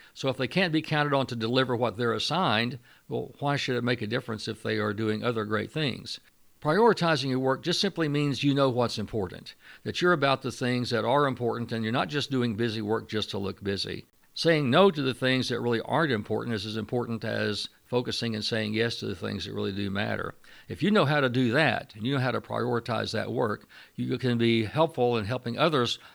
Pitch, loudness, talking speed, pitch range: 120 Hz, -27 LUFS, 230 wpm, 110-135 Hz